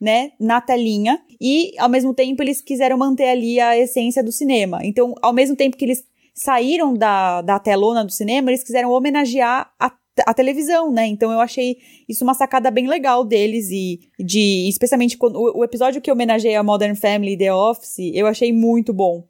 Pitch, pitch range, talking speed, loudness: 245 Hz, 220-260 Hz, 195 wpm, -17 LUFS